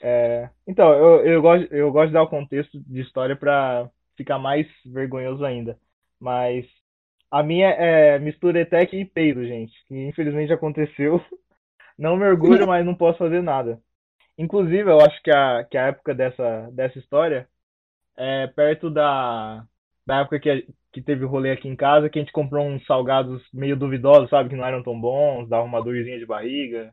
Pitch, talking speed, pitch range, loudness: 140 Hz, 185 wpm, 125-155 Hz, -20 LUFS